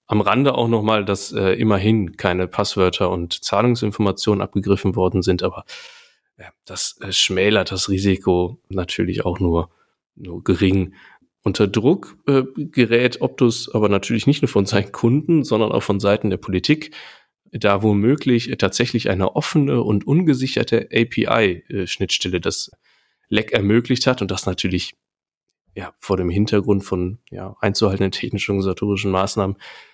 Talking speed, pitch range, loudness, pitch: 145 wpm, 95-120 Hz, -19 LUFS, 100 Hz